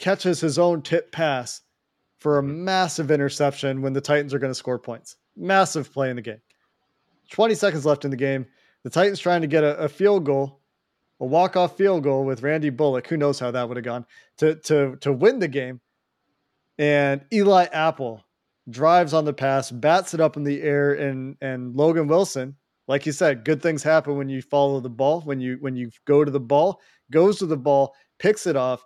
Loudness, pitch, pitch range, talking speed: -22 LUFS, 145 Hz, 135-160 Hz, 210 wpm